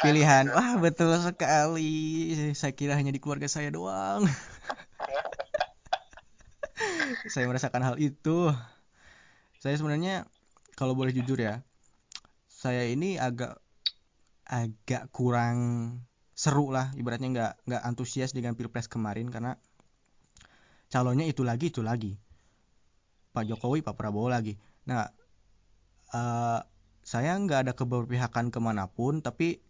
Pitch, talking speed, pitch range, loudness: 125 Hz, 105 wpm, 115-150 Hz, -30 LUFS